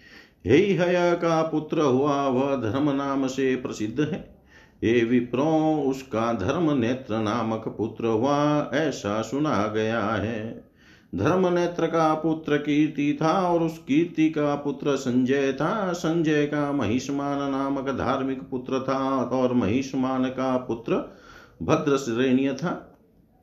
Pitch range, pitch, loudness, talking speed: 125-155 Hz, 135 Hz, -24 LUFS, 125 wpm